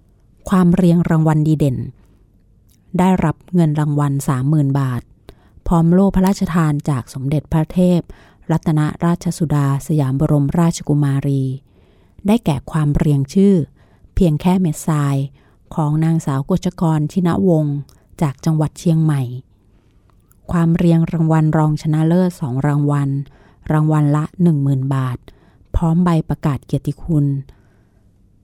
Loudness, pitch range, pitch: -17 LUFS, 135-165 Hz, 150 Hz